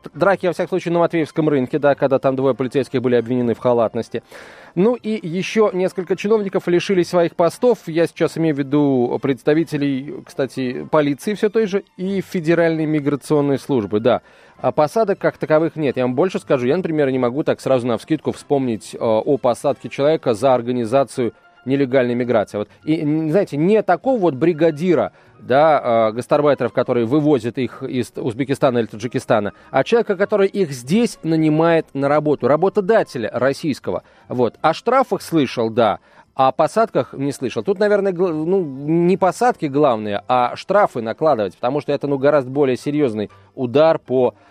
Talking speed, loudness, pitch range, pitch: 165 wpm, -18 LUFS, 130-180 Hz, 150 Hz